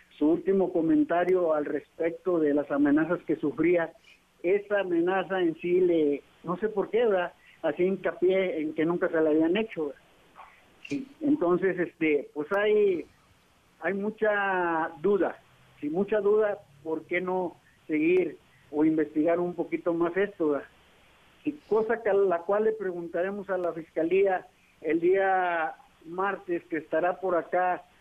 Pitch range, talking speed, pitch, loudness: 160-195 Hz, 145 wpm, 175 Hz, -27 LUFS